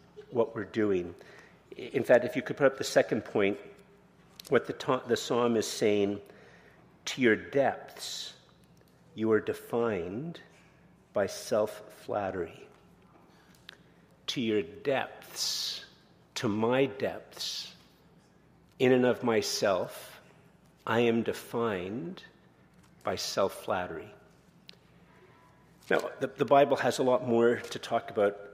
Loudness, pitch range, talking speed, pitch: -30 LUFS, 110-135 Hz, 120 wpm, 120 Hz